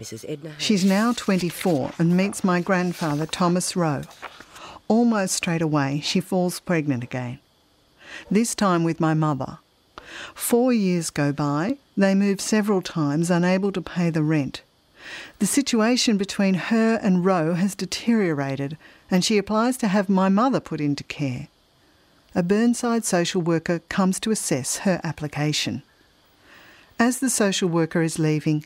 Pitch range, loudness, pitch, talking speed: 160-205 Hz, -22 LUFS, 180 Hz, 140 wpm